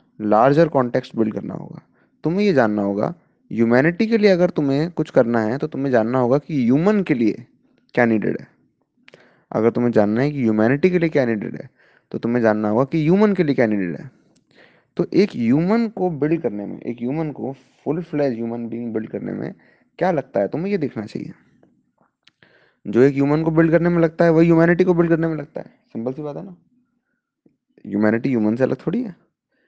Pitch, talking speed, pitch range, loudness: 140 Hz, 200 wpm, 115-170 Hz, -19 LUFS